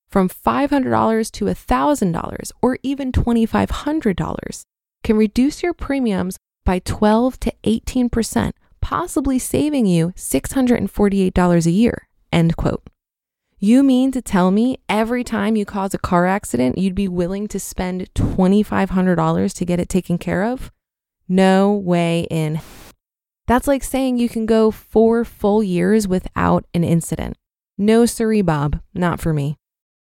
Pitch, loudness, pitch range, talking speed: 205 Hz, -18 LUFS, 175-235 Hz, 140 wpm